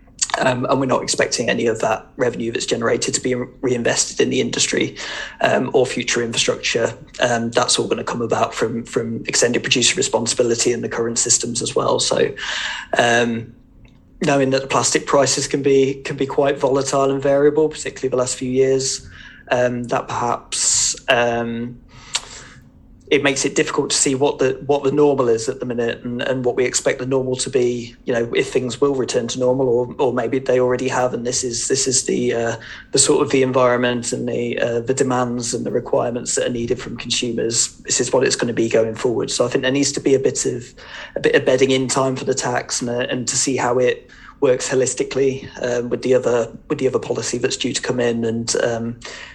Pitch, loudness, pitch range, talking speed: 125 Hz, -19 LUFS, 120-135 Hz, 215 wpm